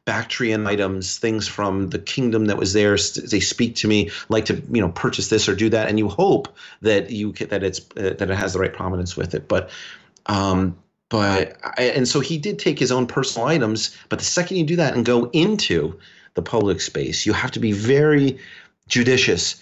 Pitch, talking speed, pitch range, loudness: 110 Hz, 210 wpm, 100-130 Hz, -20 LUFS